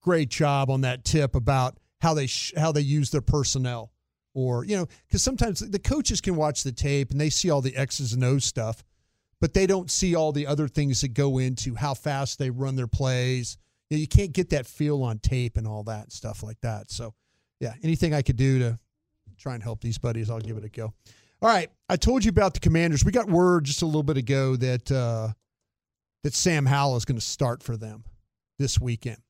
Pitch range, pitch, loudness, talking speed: 115-150 Hz, 135 Hz, -25 LUFS, 230 wpm